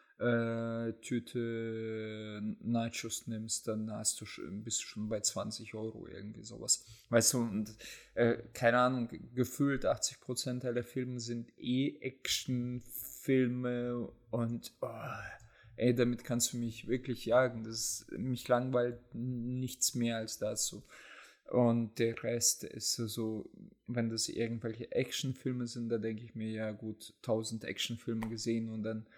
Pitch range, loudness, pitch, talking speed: 110-125 Hz, -35 LUFS, 115 Hz, 140 wpm